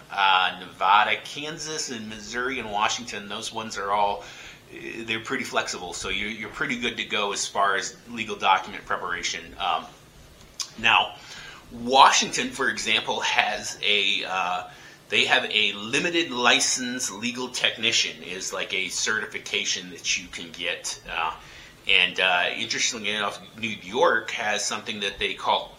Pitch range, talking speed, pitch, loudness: 105-135 Hz, 135 wpm, 110 Hz, -24 LUFS